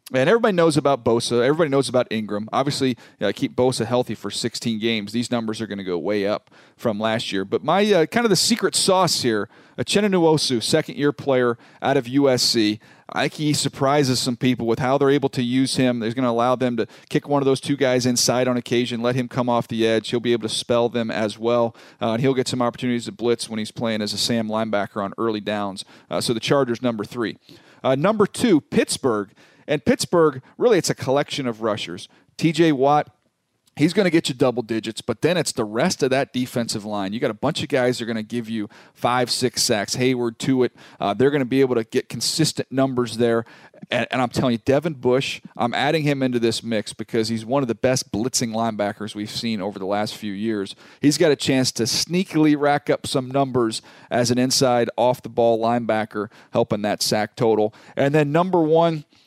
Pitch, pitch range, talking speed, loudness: 125 Hz, 115-140 Hz, 220 wpm, -21 LUFS